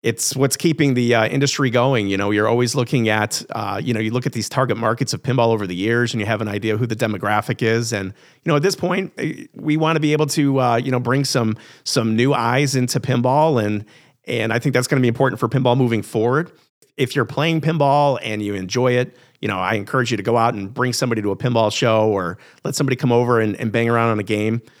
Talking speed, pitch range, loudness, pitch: 260 wpm, 110-135 Hz, -19 LUFS, 120 Hz